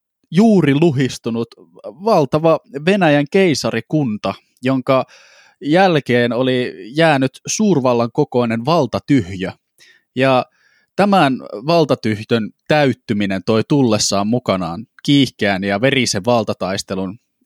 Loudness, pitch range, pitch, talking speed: -16 LUFS, 115-155 Hz, 130 Hz, 80 wpm